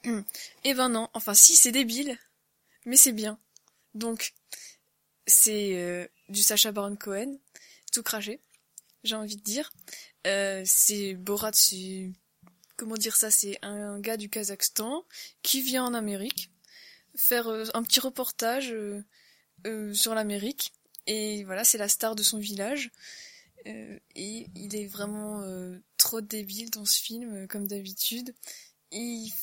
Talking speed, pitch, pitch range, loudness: 145 wpm, 215 Hz, 205-235 Hz, -24 LUFS